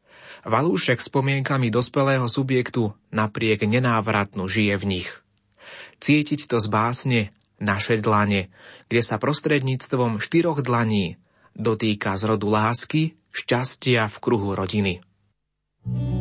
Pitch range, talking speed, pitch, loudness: 105-125 Hz, 105 wpm, 110 Hz, -22 LUFS